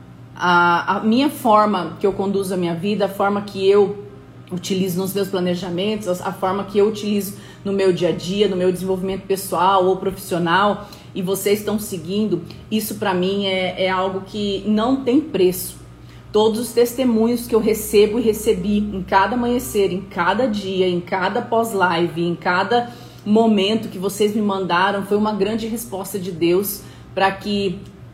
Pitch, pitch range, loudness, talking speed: 195 Hz, 185-215 Hz, -19 LUFS, 170 wpm